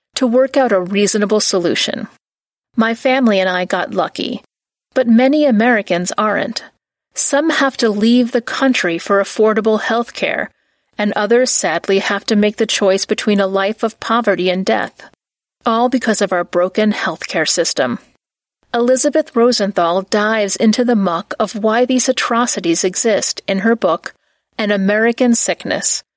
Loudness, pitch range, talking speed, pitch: -15 LUFS, 195-245 Hz, 150 wpm, 220 Hz